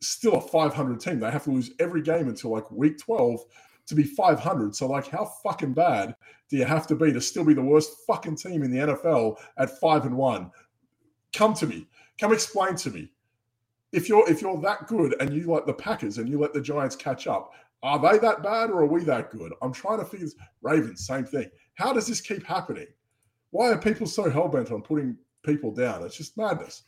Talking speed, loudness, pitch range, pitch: 225 wpm, -25 LUFS, 130-185 Hz, 150 Hz